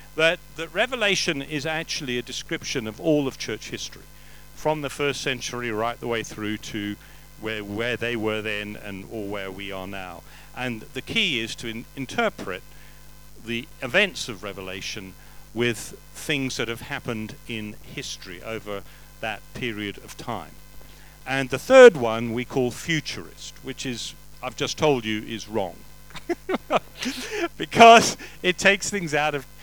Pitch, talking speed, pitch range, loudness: 120 Hz, 155 wpm, 110-150 Hz, -24 LUFS